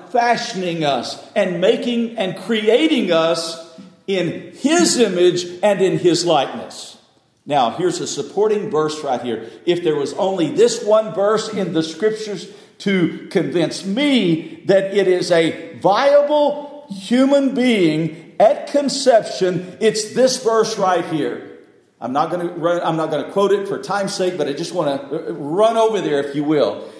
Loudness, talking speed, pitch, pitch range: -18 LUFS, 160 wpm, 195 Hz, 170-230 Hz